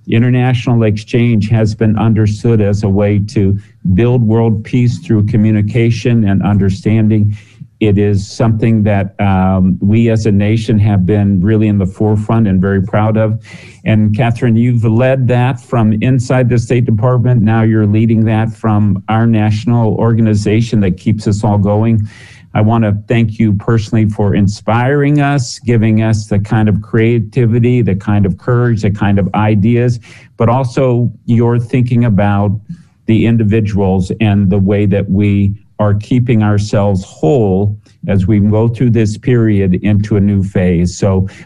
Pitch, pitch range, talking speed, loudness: 110 Hz, 105-115 Hz, 155 wpm, -12 LUFS